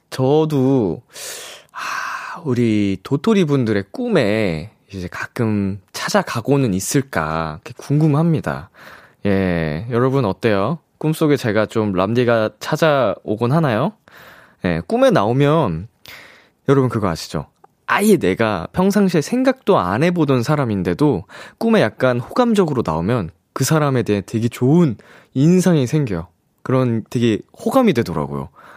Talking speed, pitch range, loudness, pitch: 265 characters per minute, 105-155 Hz, -18 LUFS, 125 Hz